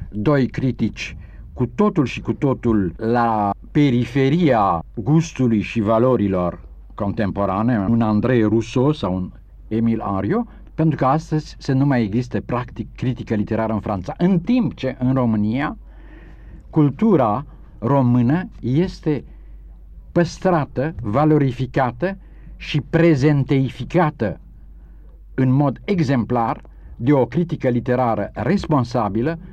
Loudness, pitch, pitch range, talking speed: -19 LUFS, 125 Hz, 110-150 Hz, 105 wpm